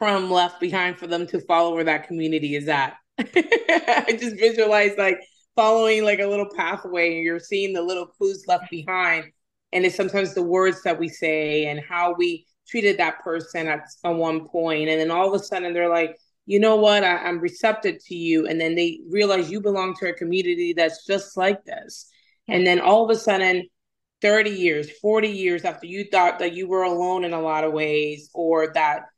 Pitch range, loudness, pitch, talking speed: 165-200 Hz, -22 LUFS, 180 Hz, 205 wpm